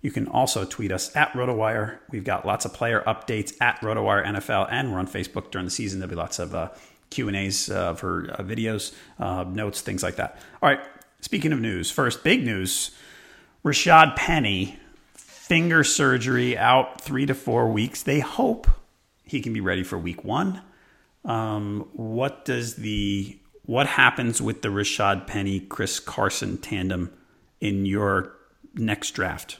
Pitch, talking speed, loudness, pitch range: 105 Hz, 170 wpm, -24 LUFS, 95-130 Hz